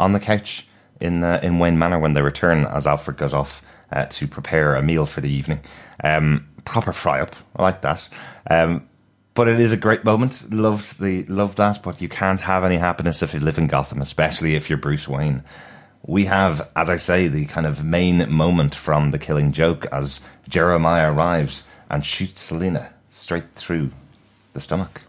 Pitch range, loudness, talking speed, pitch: 75-95 Hz, -20 LUFS, 190 wpm, 80 Hz